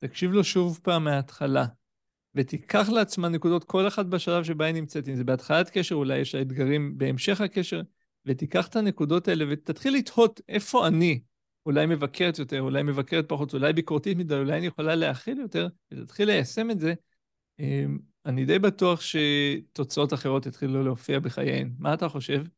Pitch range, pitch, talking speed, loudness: 140-180 Hz, 160 Hz, 165 wpm, -26 LUFS